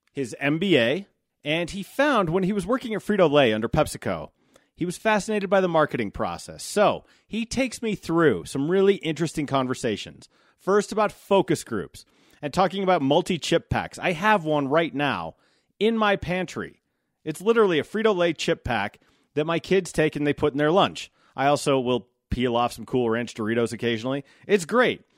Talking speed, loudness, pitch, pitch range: 185 wpm, -24 LUFS, 160 Hz, 135-195 Hz